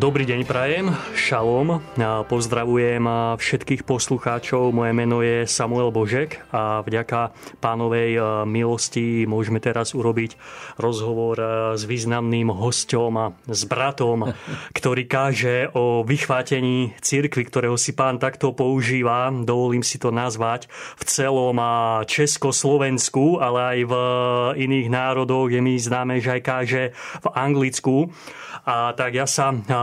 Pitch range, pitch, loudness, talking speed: 115-130 Hz, 125 Hz, -21 LUFS, 120 wpm